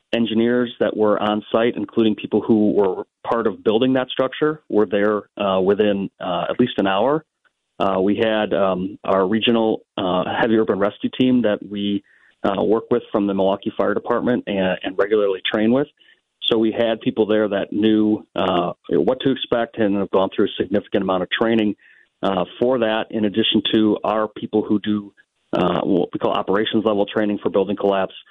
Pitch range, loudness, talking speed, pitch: 100-115 Hz, -20 LUFS, 190 wpm, 110 Hz